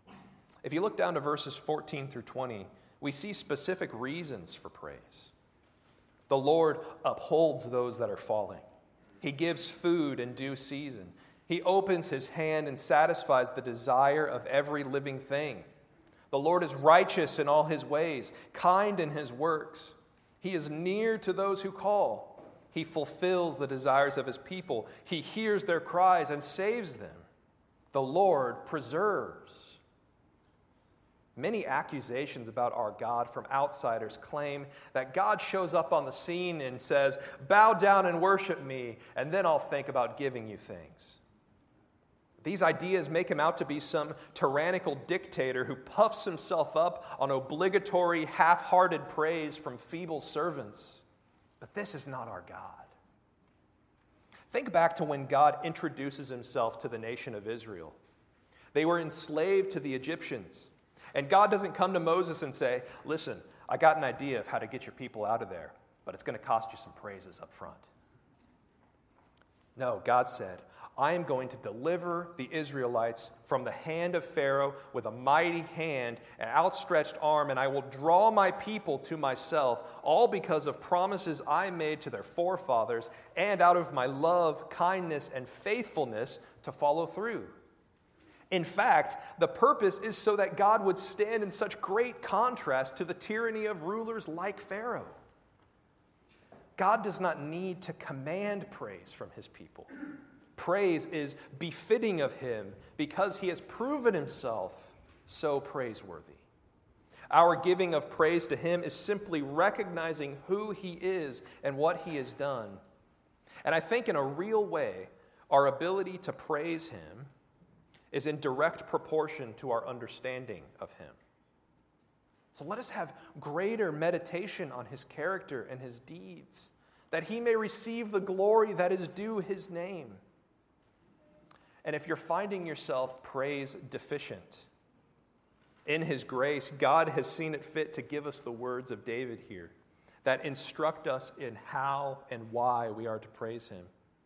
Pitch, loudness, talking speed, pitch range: 155 Hz, -31 LUFS, 155 wpm, 135-185 Hz